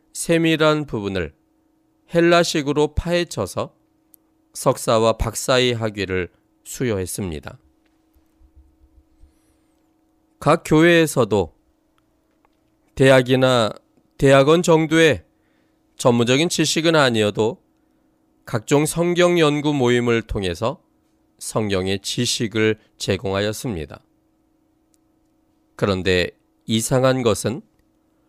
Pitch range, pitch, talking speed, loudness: 110-170 Hz, 135 Hz, 190 characters per minute, -19 LUFS